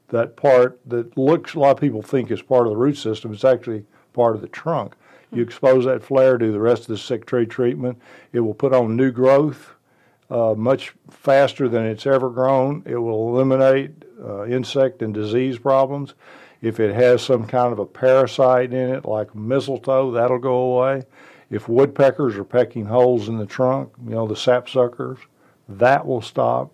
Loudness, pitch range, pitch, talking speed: -19 LUFS, 115-135 Hz, 125 Hz, 190 wpm